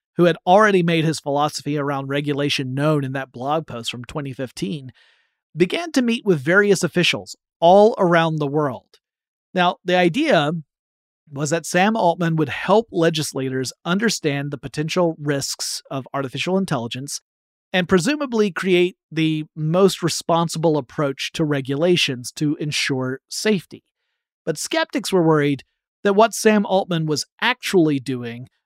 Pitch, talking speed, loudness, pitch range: 160 Hz, 135 wpm, -20 LUFS, 140-185 Hz